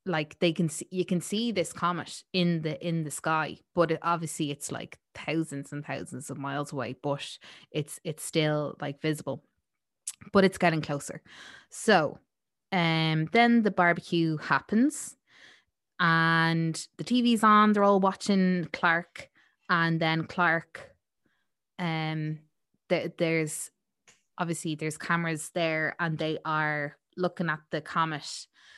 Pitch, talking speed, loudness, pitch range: 165 Hz, 140 wpm, -28 LUFS, 155-180 Hz